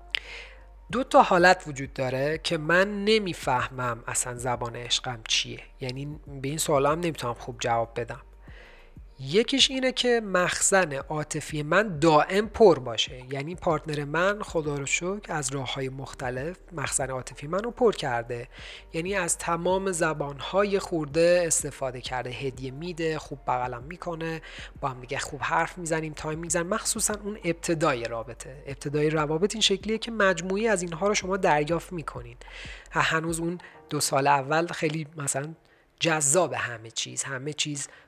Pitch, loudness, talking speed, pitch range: 155 Hz, -26 LUFS, 150 wpm, 135-180 Hz